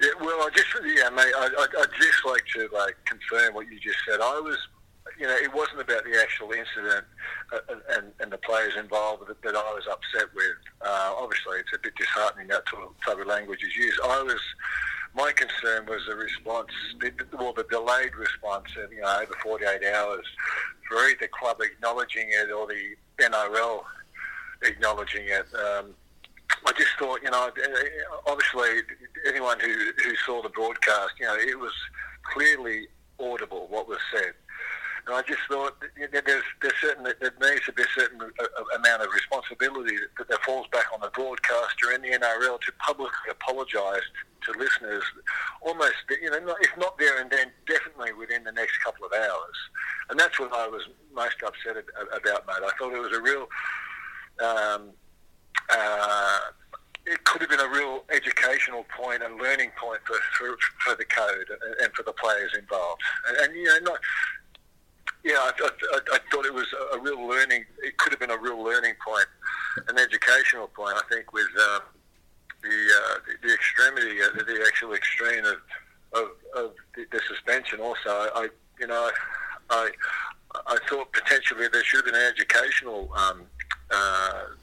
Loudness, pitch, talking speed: -25 LUFS, 395 Hz, 175 wpm